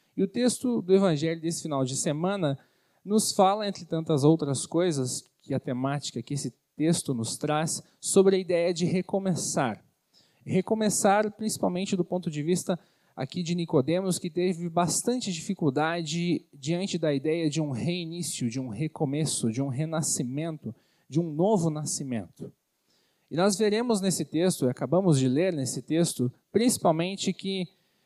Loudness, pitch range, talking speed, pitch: -27 LUFS, 150-185 Hz, 150 wpm, 170 Hz